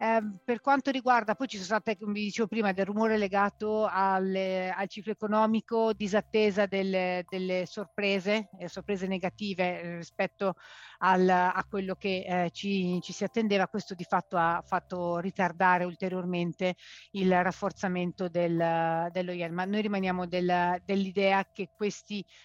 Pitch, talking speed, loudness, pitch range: 190 Hz, 145 wpm, -29 LUFS, 180-210 Hz